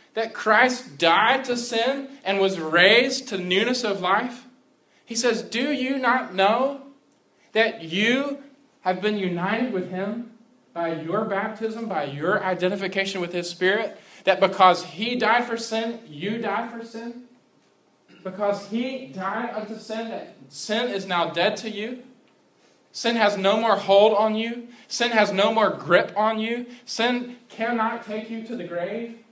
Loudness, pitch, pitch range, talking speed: -23 LUFS, 220 Hz, 195-240 Hz, 160 wpm